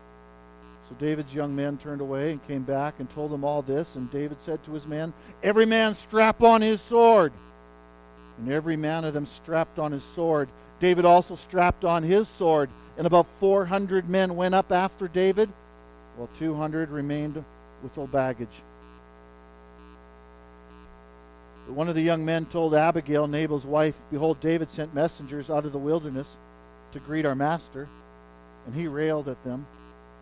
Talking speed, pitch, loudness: 165 wpm, 150 Hz, -25 LUFS